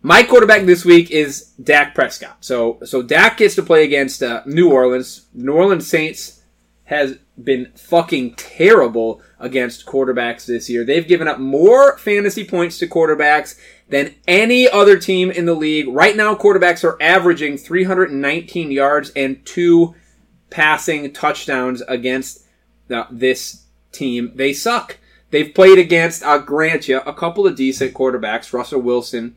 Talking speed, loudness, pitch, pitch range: 150 wpm, -14 LUFS, 150 Hz, 130-180 Hz